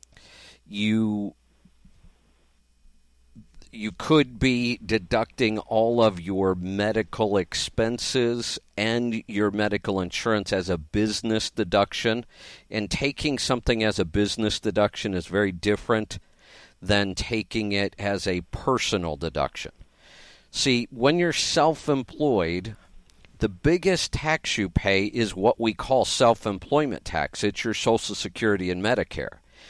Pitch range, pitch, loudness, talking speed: 95-115 Hz, 105 Hz, -25 LUFS, 115 wpm